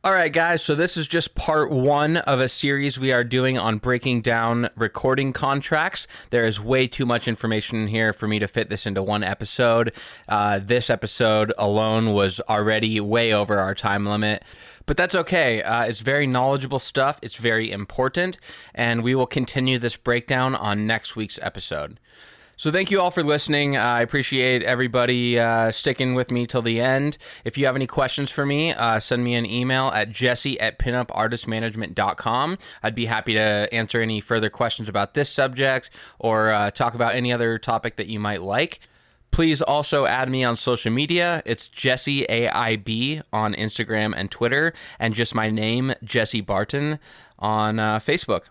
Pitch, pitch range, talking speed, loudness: 120 Hz, 110-135 Hz, 180 wpm, -22 LUFS